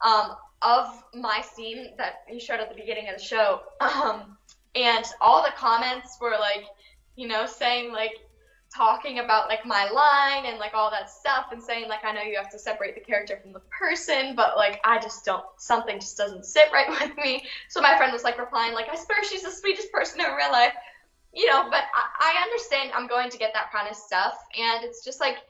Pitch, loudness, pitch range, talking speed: 230 Hz, -24 LUFS, 215-265 Hz, 220 wpm